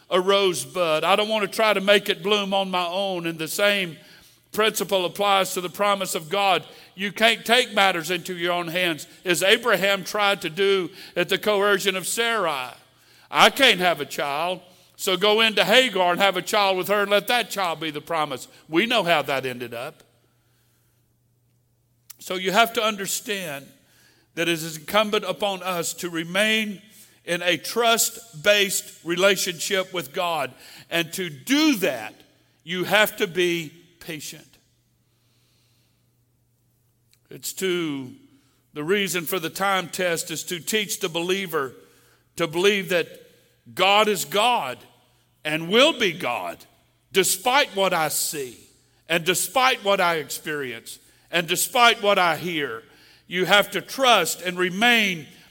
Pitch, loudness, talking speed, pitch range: 180 Hz, -22 LUFS, 155 wpm, 155-205 Hz